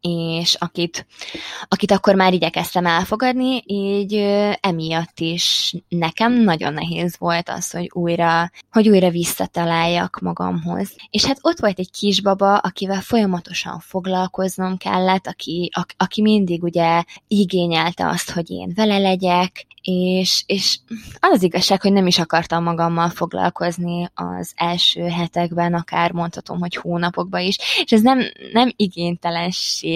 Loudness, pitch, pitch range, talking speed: -19 LUFS, 180 Hz, 170-200 Hz, 130 wpm